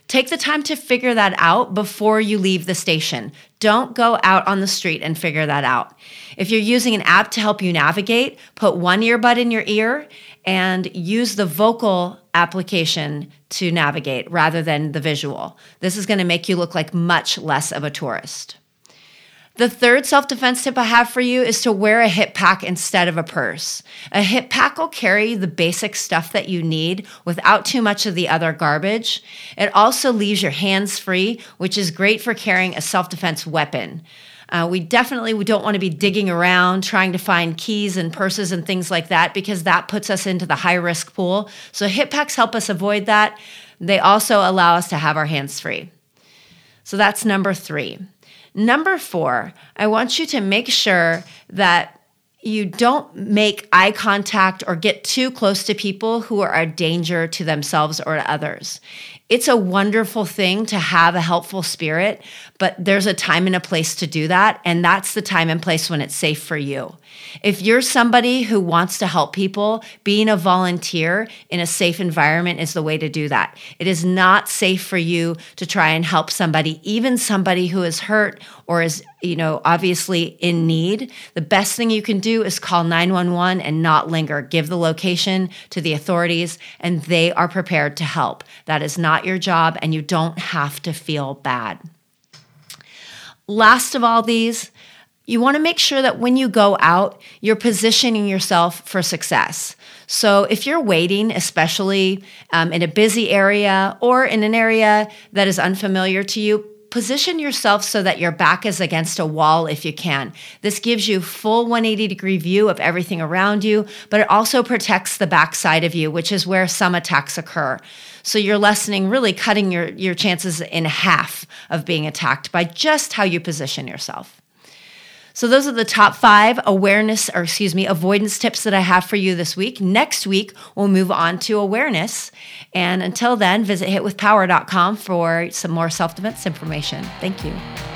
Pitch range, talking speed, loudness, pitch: 170-215 Hz, 190 wpm, -17 LUFS, 190 Hz